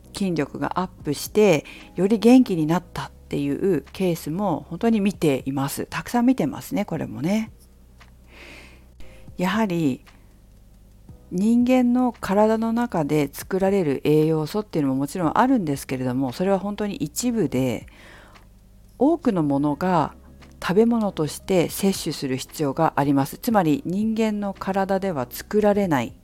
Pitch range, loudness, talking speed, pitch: 130-200 Hz, -22 LUFS, 290 characters per minute, 160 Hz